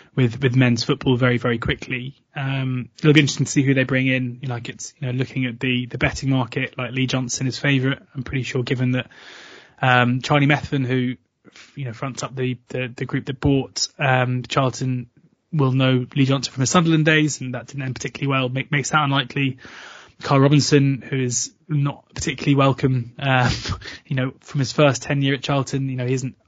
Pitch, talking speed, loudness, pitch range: 135 Hz, 215 wpm, -21 LUFS, 125-140 Hz